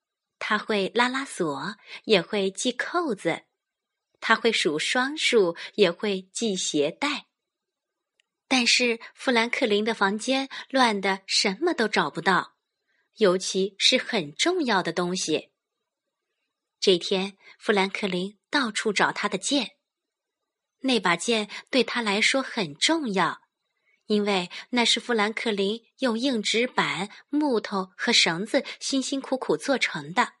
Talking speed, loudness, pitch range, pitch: 180 characters per minute, -24 LUFS, 195-255 Hz, 220 Hz